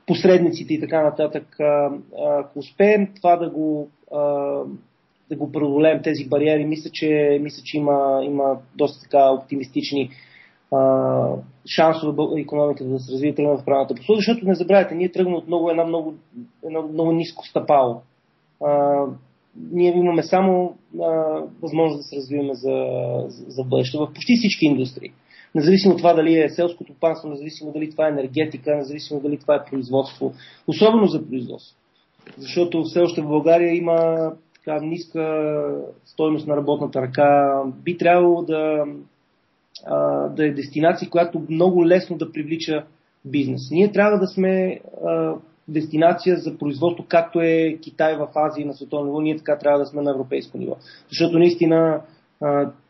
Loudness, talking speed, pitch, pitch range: -20 LUFS, 150 wpm, 155 Hz, 145-165 Hz